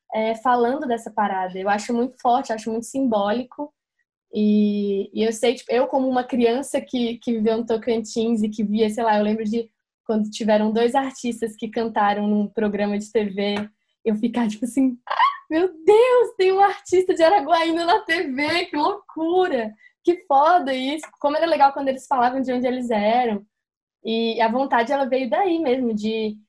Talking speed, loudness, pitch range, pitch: 180 wpm, -21 LUFS, 220-285 Hz, 240 Hz